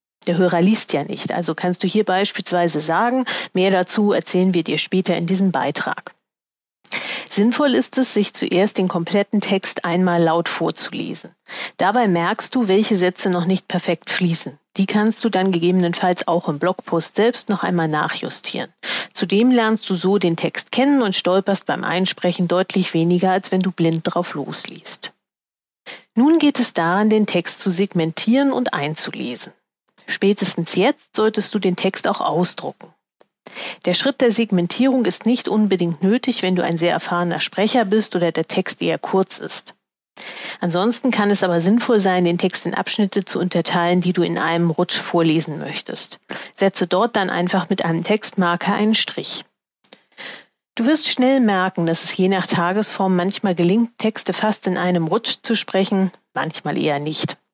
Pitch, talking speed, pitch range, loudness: 190 Hz, 165 wpm, 175-215 Hz, -19 LUFS